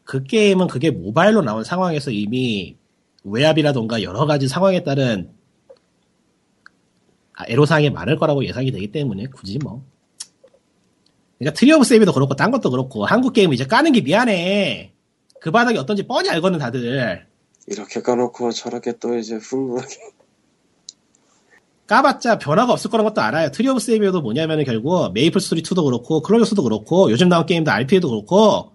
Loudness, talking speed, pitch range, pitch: -18 LUFS, 375 characters per minute, 130-205 Hz, 160 Hz